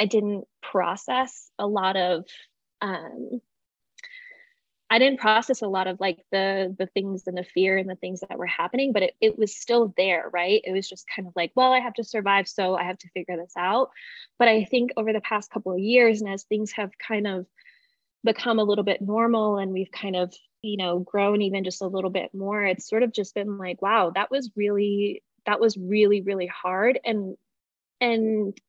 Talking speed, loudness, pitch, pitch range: 210 wpm, -25 LUFS, 205 Hz, 190-230 Hz